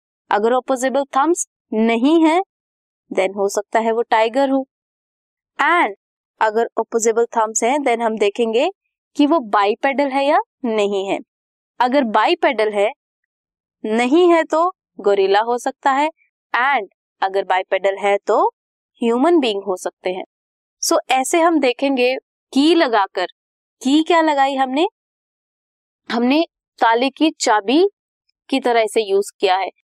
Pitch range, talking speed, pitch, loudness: 220-315 Hz, 135 wpm, 260 Hz, -18 LUFS